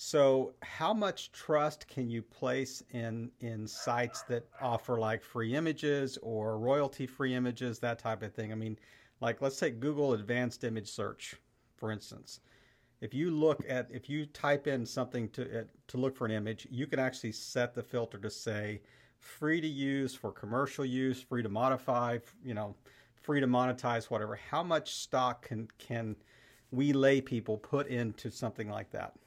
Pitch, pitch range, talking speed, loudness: 125 Hz, 115-135 Hz, 175 wpm, -35 LUFS